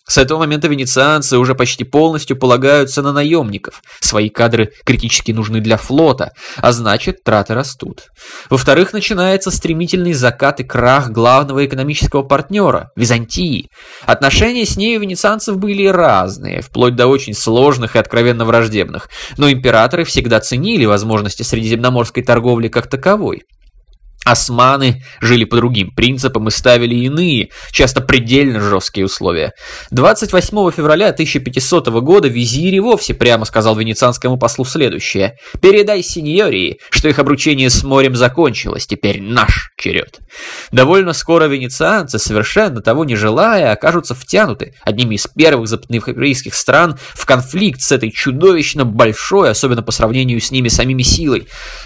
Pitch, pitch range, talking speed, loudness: 130 Hz, 115-155 Hz, 135 wpm, -12 LUFS